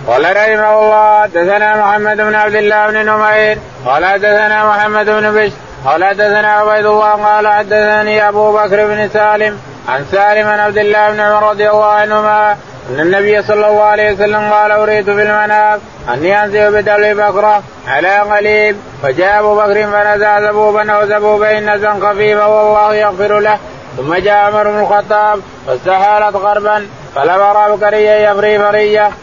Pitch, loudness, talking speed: 210 Hz, -10 LUFS, 150 wpm